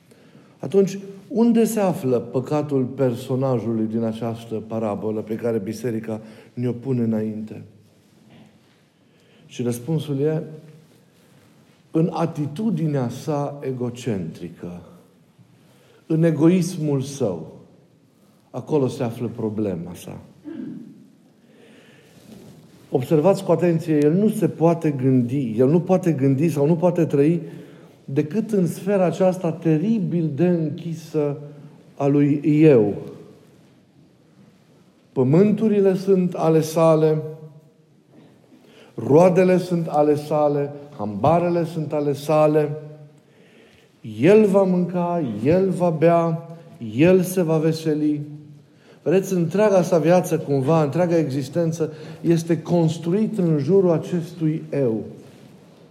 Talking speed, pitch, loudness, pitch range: 100 wpm, 155 Hz, -20 LUFS, 140-175 Hz